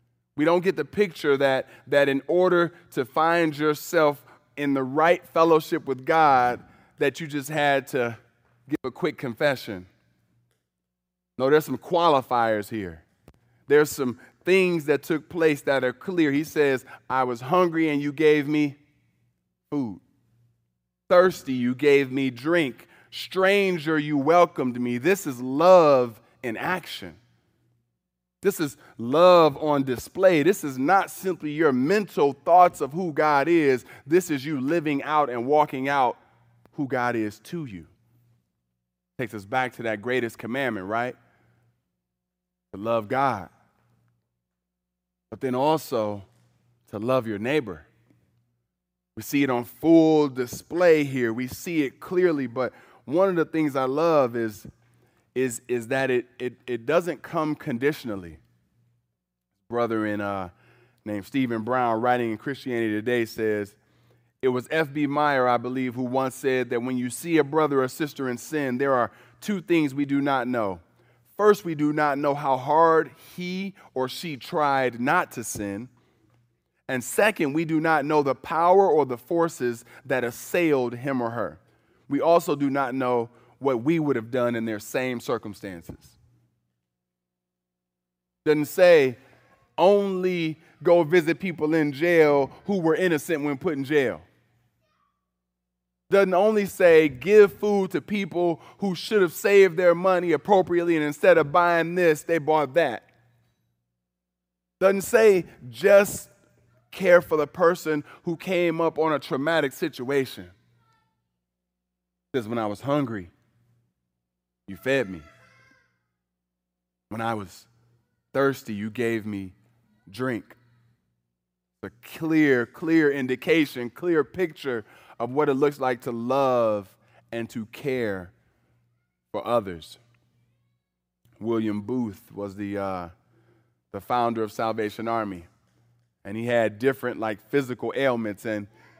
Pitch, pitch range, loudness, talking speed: 125 Hz, 105-155 Hz, -23 LUFS, 140 wpm